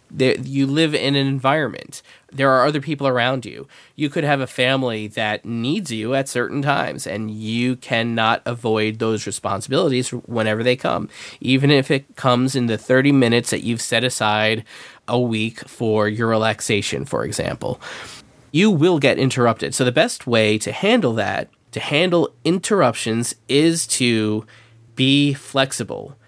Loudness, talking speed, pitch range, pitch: -19 LUFS, 155 wpm, 110-135 Hz, 125 Hz